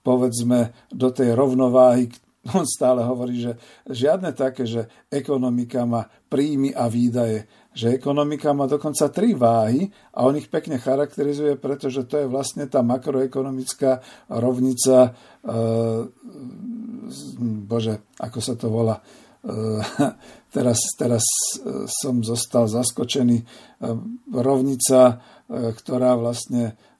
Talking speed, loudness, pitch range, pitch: 105 wpm, -21 LUFS, 120-135 Hz, 125 Hz